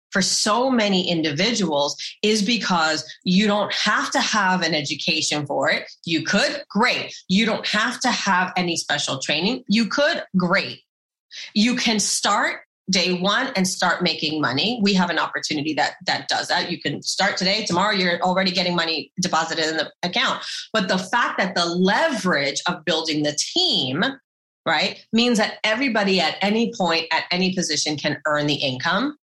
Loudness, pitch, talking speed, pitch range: -20 LUFS, 185 Hz, 170 wpm, 160-210 Hz